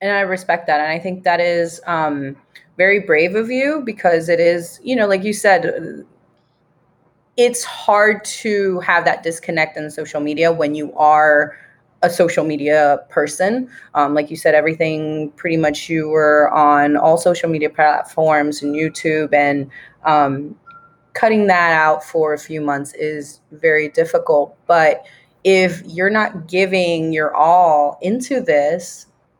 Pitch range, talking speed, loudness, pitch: 150-190 Hz, 155 wpm, -16 LUFS, 165 Hz